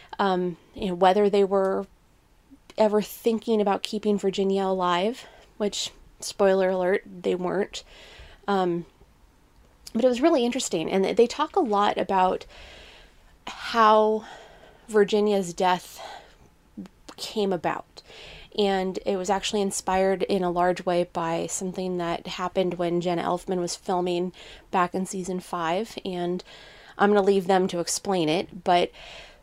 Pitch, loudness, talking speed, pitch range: 190 Hz, -25 LUFS, 135 wpm, 180-205 Hz